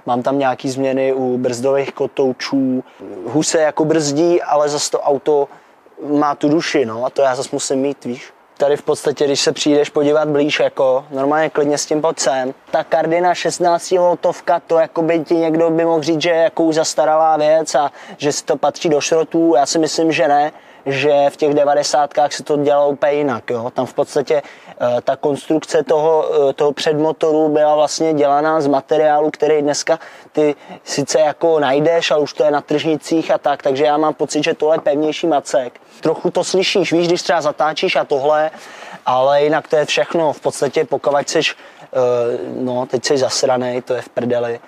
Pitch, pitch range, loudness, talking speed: 150 Hz, 140-160 Hz, -16 LUFS, 195 wpm